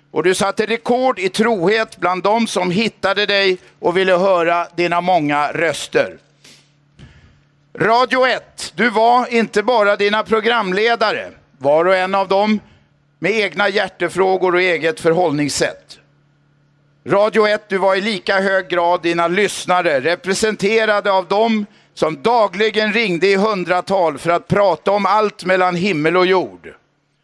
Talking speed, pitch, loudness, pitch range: 140 wpm, 190 Hz, -16 LUFS, 175-215 Hz